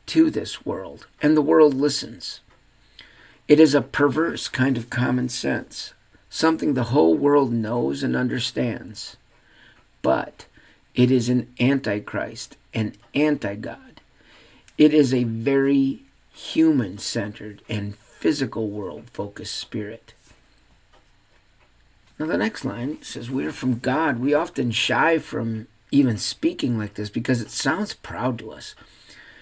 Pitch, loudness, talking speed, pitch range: 125 Hz, -22 LUFS, 125 wpm, 110-145 Hz